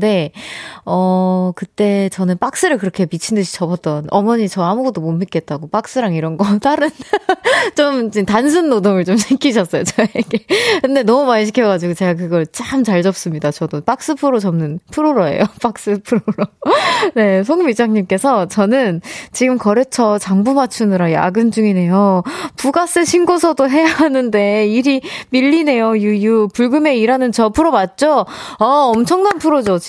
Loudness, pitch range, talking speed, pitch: -14 LUFS, 190-275 Hz, 315 characters per minute, 225 Hz